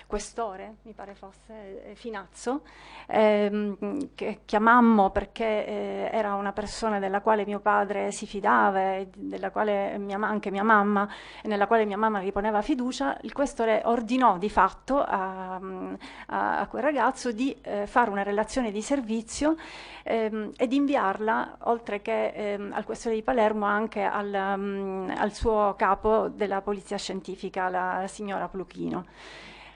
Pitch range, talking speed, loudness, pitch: 200-225 Hz, 145 wpm, -27 LUFS, 210 Hz